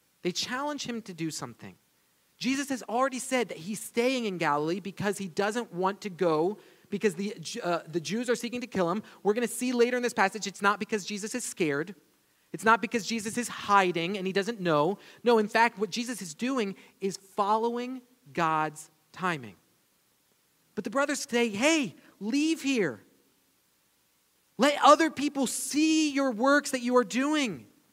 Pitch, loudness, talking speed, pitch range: 215 Hz, -28 LUFS, 180 wpm, 180-250 Hz